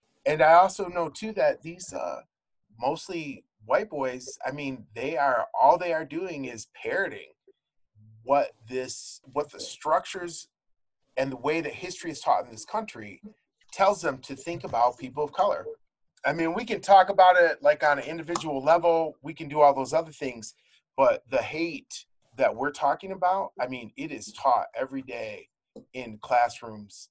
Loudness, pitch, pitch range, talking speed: -26 LUFS, 160 Hz, 130-195 Hz, 170 wpm